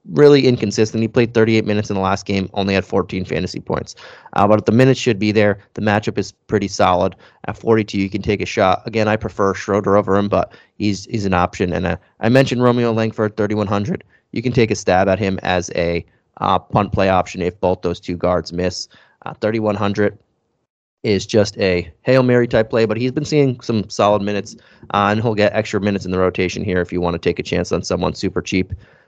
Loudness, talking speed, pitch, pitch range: -18 LUFS, 225 wpm, 105 Hz, 95-110 Hz